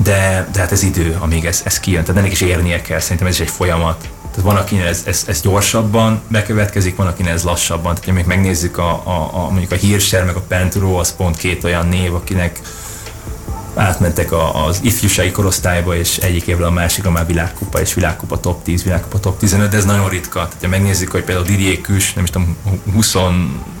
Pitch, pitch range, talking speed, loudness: 90 Hz, 85-100 Hz, 210 wpm, -15 LUFS